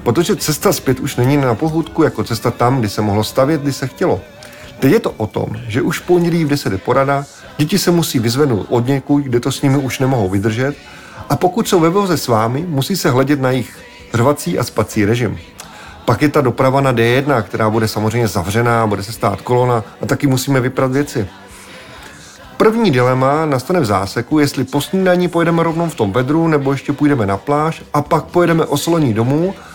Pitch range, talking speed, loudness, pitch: 115-155 Hz, 200 wpm, -15 LUFS, 135 Hz